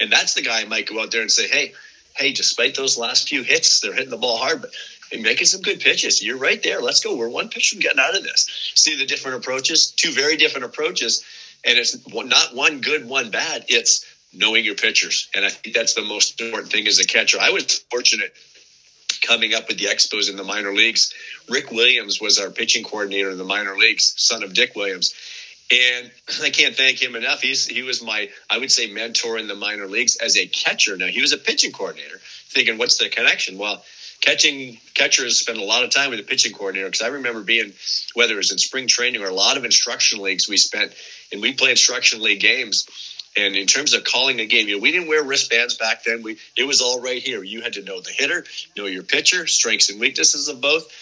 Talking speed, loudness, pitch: 235 wpm, -17 LUFS, 130 Hz